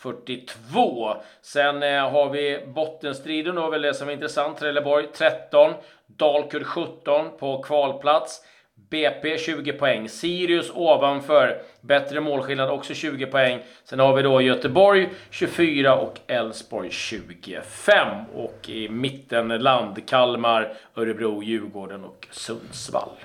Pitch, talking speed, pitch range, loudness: 140 Hz, 115 wpm, 125-150 Hz, -22 LUFS